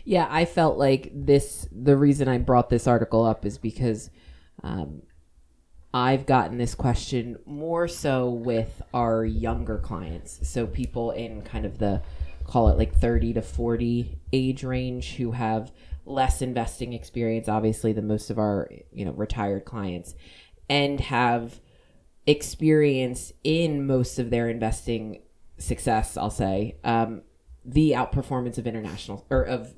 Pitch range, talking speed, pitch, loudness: 100-130 Hz, 145 wpm, 115 Hz, -25 LUFS